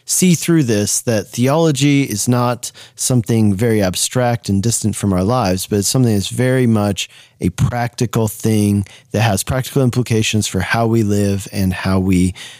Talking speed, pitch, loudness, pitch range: 165 wpm, 115 Hz, -16 LUFS, 100-125 Hz